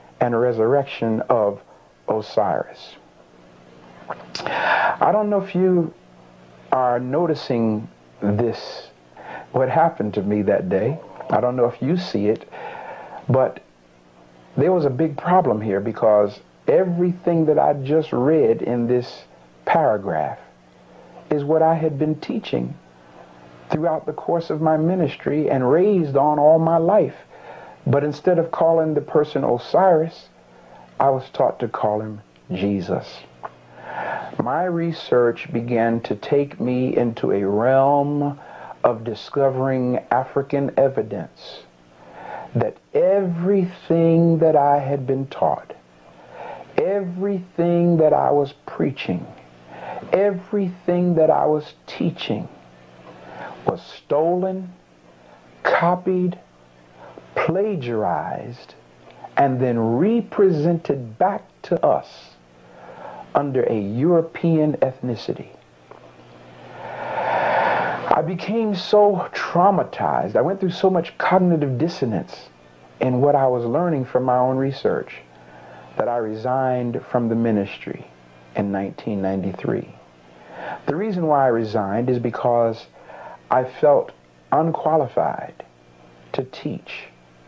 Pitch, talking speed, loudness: 125 Hz, 110 wpm, -20 LUFS